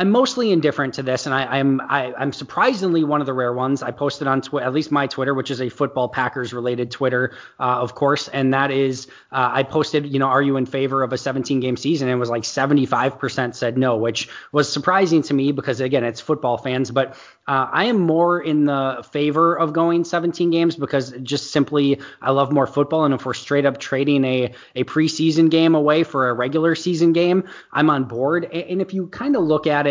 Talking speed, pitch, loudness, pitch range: 225 wpm, 140 Hz, -20 LUFS, 130-155 Hz